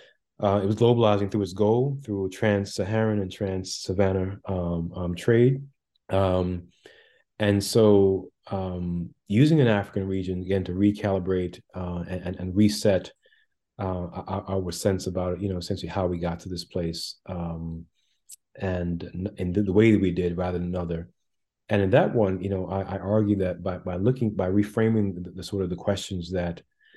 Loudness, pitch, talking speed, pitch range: -26 LUFS, 95 Hz, 170 wpm, 90-105 Hz